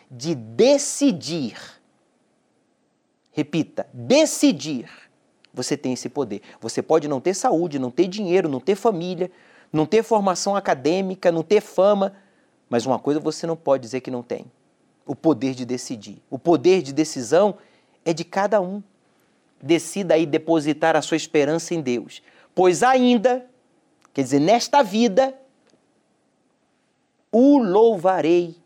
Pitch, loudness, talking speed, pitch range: 170 Hz, -21 LUFS, 135 wpm, 150-210 Hz